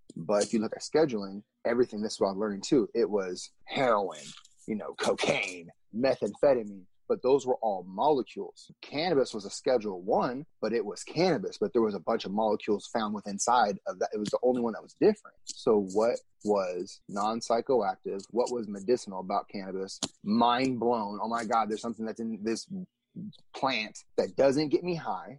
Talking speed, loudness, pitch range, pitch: 185 wpm, -30 LUFS, 105-125 Hz, 115 Hz